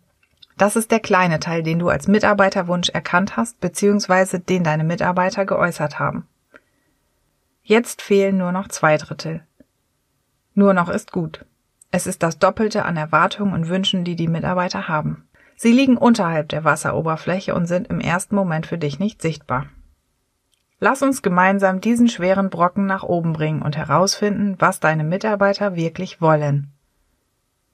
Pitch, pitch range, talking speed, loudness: 185 Hz, 160-200 Hz, 150 wpm, -19 LUFS